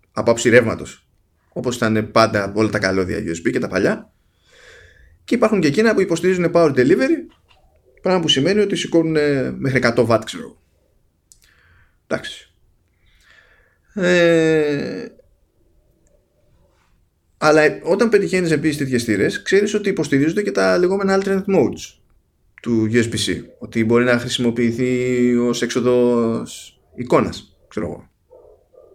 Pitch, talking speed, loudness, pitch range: 125 Hz, 115 wpm, -18 LUFS, 110-175 Hz